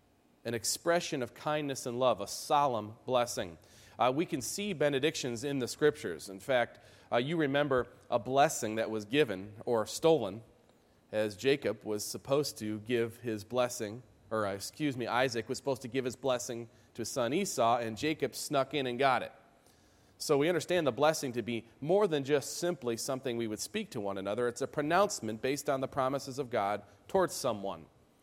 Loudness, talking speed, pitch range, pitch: -33 LUFS, 185 wpm, 110-145 Hz, 125 Hz